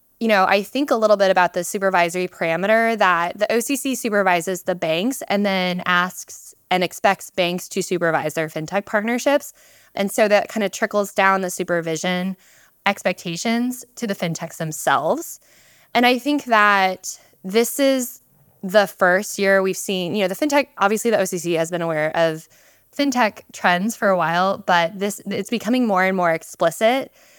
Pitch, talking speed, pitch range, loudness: 195 Hz, 170 wpm, 180-225 Hz, -20 LUFS